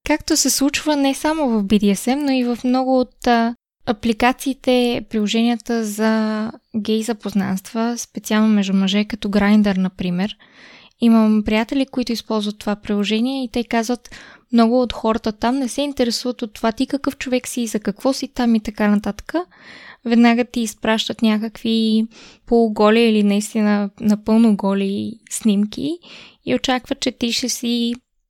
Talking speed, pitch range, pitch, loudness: 145 wpm, 215-250 Hz, 230 Hz, -19 LUFS